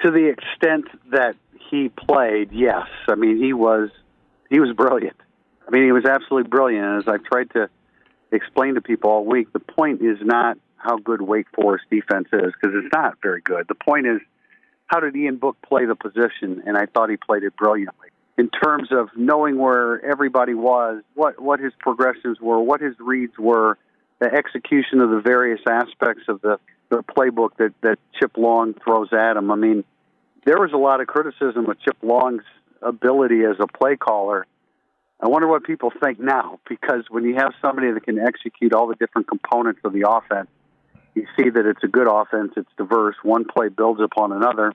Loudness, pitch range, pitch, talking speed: -19 LUFS, 110-135 Hz, 120 Hz, 195 wpm